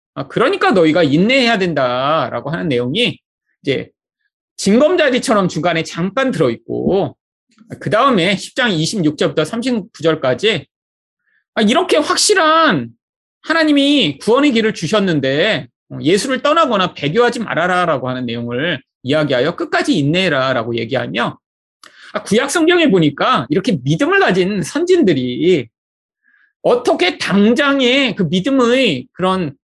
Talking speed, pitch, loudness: 280 characters per minute, 215 Hz, -15 LUFS